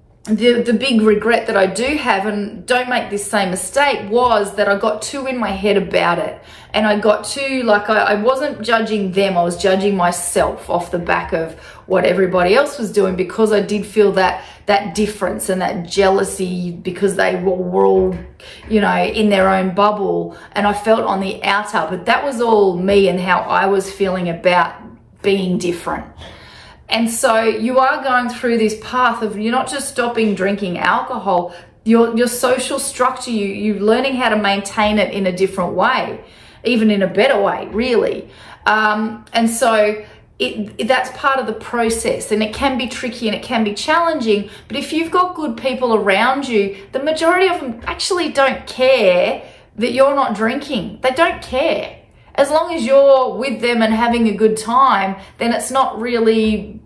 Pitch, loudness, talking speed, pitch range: 215 Hz, -16 LUFS, 190 wpm, 200-250 Hz